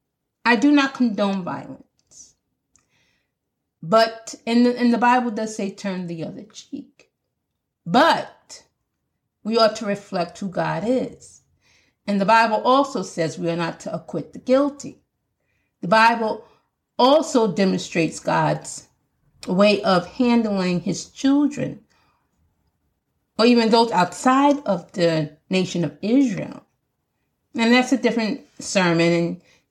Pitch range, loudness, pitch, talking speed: 175-245 Hz, -20 LUFS, 210 Hz, 125 wpm